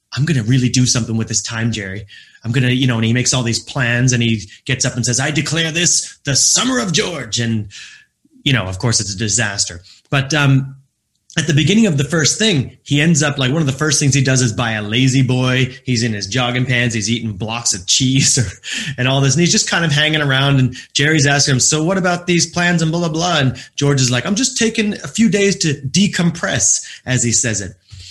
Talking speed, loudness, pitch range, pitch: 245 wpm, -15 LUFS, 120-155 Hz, 130 Hz